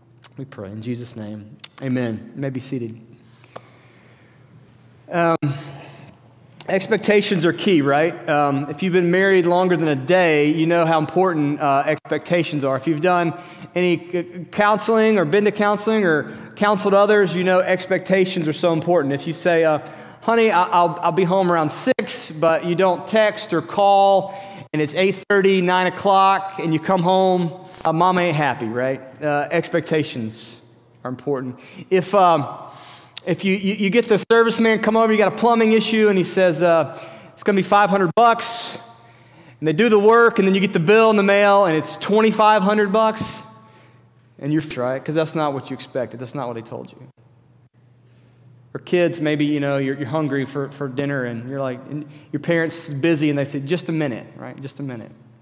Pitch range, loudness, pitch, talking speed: 135-190 Hz, -18 LUFS, 165 Hz, 190 wpm